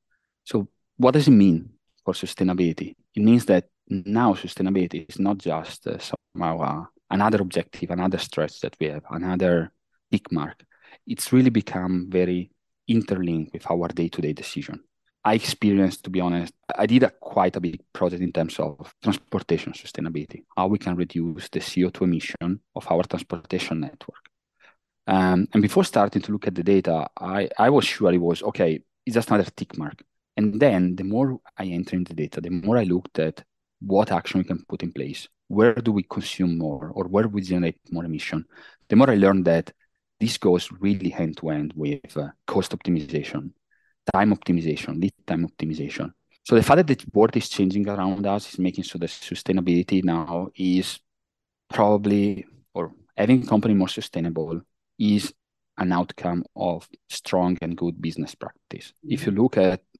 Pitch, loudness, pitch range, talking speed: 90 Hz, -23 LUFS, 85-100 Hz, 175 wpm